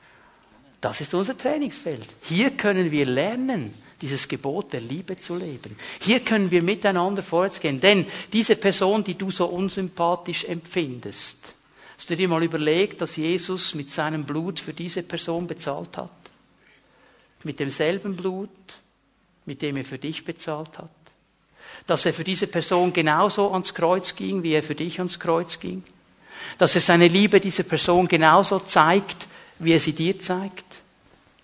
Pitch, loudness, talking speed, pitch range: 175 Hz, -23 LUFS, 155 wpm, 155-190 Hz